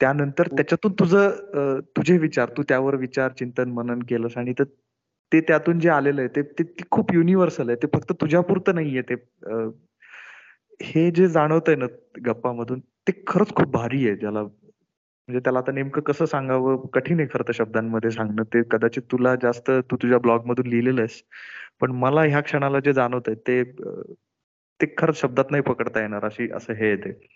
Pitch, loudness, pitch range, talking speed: 130 Hz, -22 LUFS, 120-155 Hz, 185 wpm